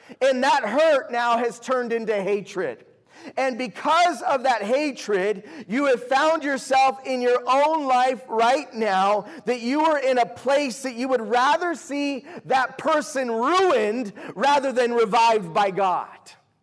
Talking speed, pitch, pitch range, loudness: 150 wpm, 255 Hz, 230-275 Hz, -22 LUFS